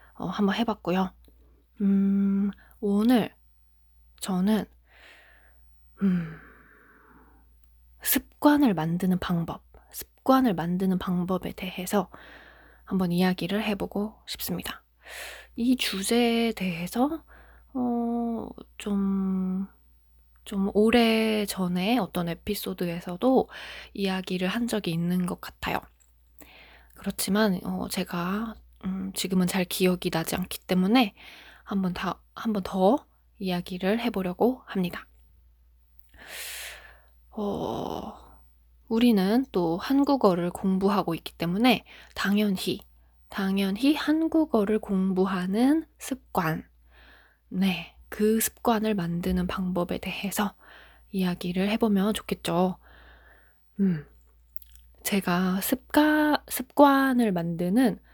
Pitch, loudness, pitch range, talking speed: 190 Hz, -26 LUFS, 170-215 Hz, 190 characters per minute